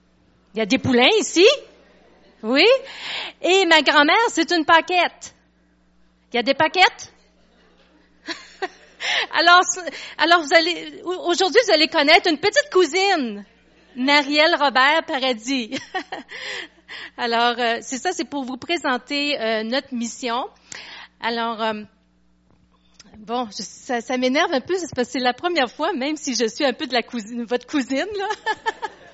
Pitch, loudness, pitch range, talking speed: 280 Hz, -19 LUFS, 240-345 Hz, 140 wpm